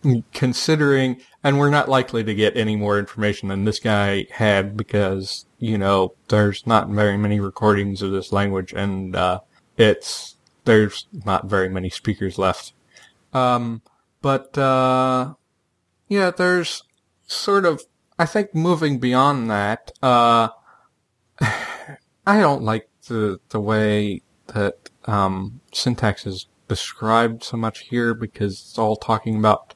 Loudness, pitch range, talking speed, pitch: -20 LUFS, 100-130 Hz, 135 wpm, 110 Hz